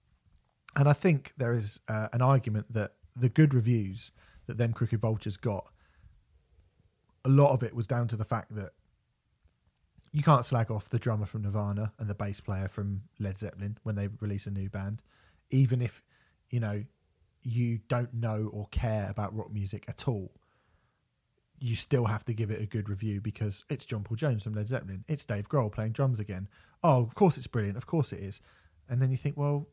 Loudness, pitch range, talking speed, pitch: -31 LUFS, 100-120 Hz, 200 wpm, 110 Hz